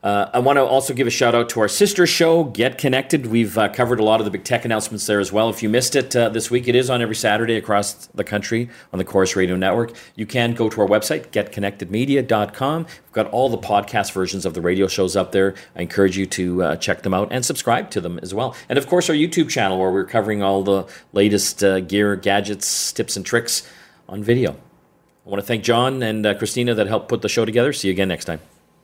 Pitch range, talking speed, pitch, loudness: 100-125 Hz, 250 wpm, 110 Hz, -19 LUFS